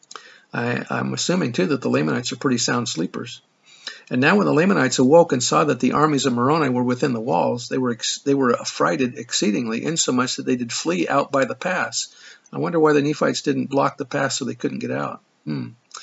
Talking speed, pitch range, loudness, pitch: 220 wpm, 120-150 Hz, -20 LUFS, 130 Hz